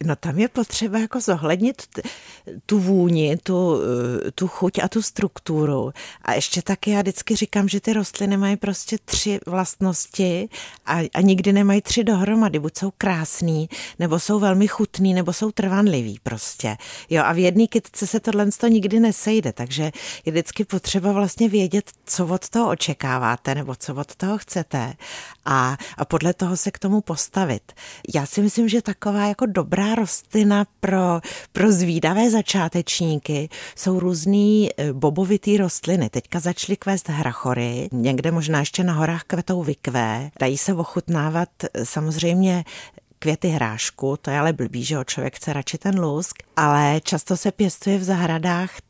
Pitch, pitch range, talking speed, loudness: 180 Hz, 155-205 Hz, 155 wpm, -21 LUFS